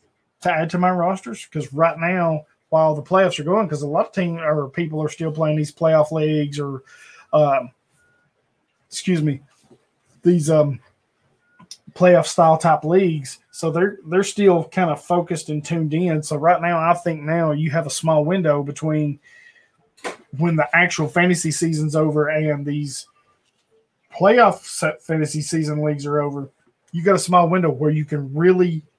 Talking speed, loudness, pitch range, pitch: 170 wpm, -19 LUFS, 150-175 Hz, 160 Hz